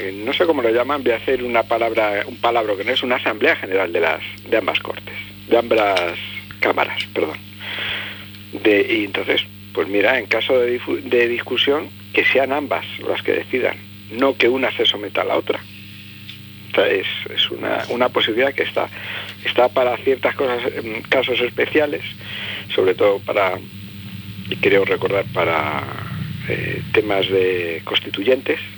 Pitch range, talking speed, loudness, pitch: 100-120 Hz, 165 wpm, -19 LUFS, 100 Hz